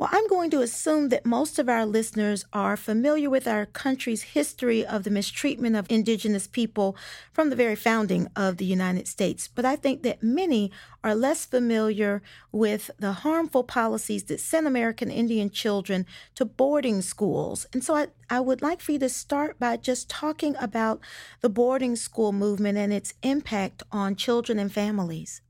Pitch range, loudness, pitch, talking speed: 210-265 Hz, -26 LUFS, 230 Hz, 175 wpm